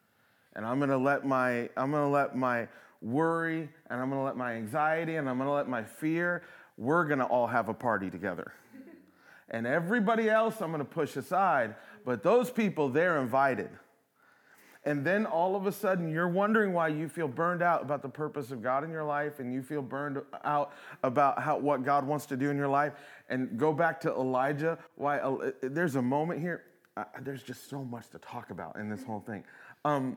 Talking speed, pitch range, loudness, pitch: 200 wpm, 130-165 Hz, -31 LUFS, 145 Hz